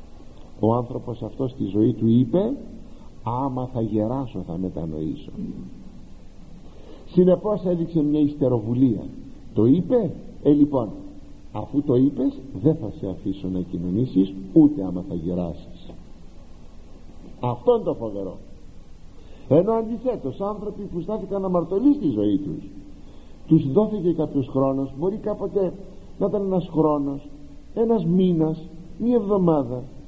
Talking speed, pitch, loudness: 120 wpm, 145 Hz, -23 LUFS